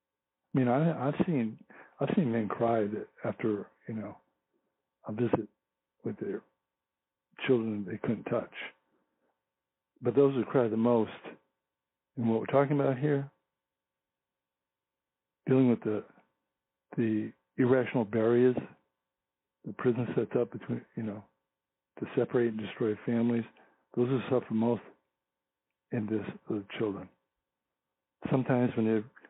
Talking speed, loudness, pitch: 130 wpm, -31 LUFS, 100 Hz